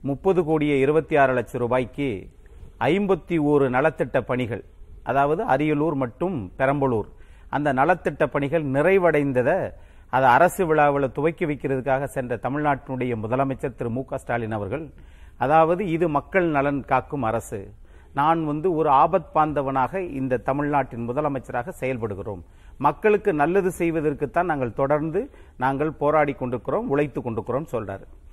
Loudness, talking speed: -23 LUFS, 120 wpm